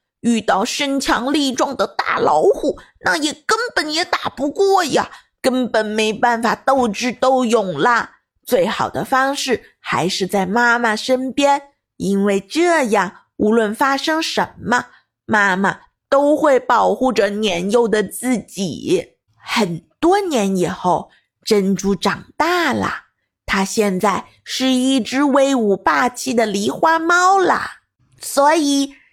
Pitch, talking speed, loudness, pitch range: 255 Hz, 185 characters per minute, -17 LUFS, 210-285 Hz